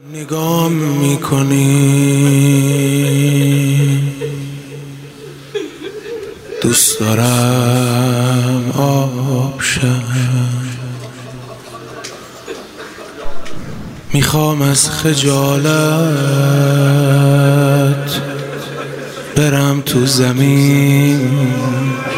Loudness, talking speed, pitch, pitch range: -13 LUFS, 30 wpm, 140 Hz, 130-145 Hz